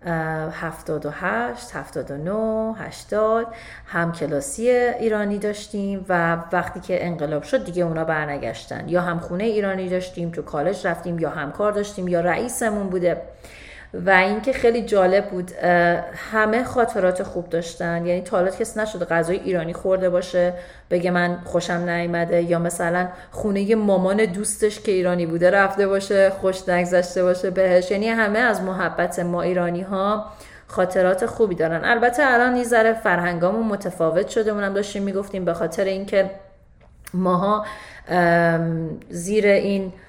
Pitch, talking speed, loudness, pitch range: 185 Hz, 140 wpm, -21 LUFS, 175-210 Hz